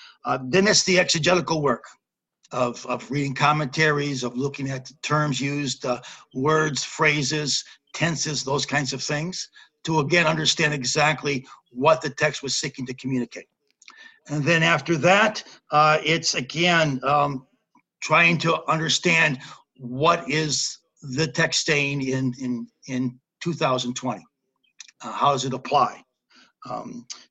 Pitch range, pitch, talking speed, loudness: 135-160 Hz, 150 Hz, 135 wpm, -22 LUFS